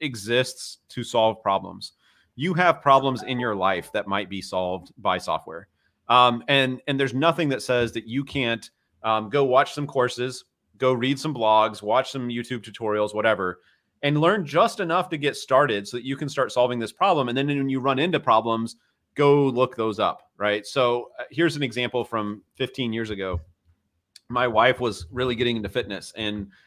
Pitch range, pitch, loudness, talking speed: 105-135 Hz, 120 Hz, -23 LUFS, 185 wpm